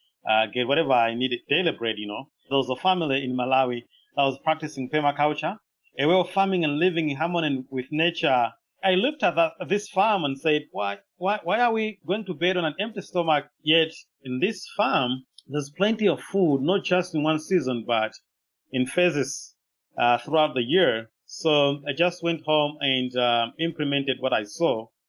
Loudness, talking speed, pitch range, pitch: -24 LUFS, 190 wpm, 130-180 Hz, 150 Hz